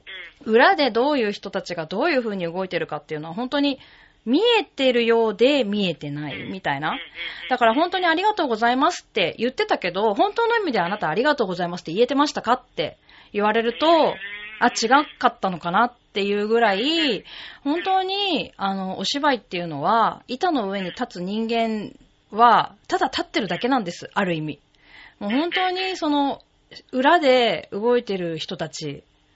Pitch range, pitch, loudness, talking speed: 195-295 Hz, 235 Hz, -22 LUFS, 360 characters per minute